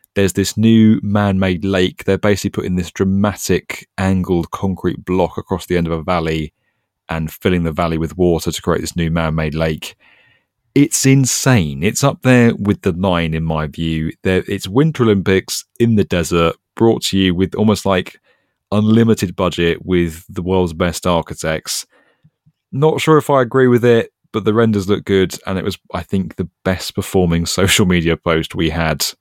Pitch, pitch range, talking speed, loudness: 95 Hz, 85-105 Hz, 180 wpm, -16 LUFS